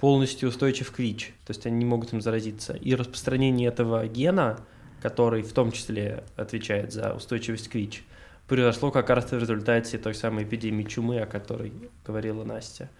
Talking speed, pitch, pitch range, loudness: 170 wpm, 115 Hz, 110-125 Hz, -27 LUFS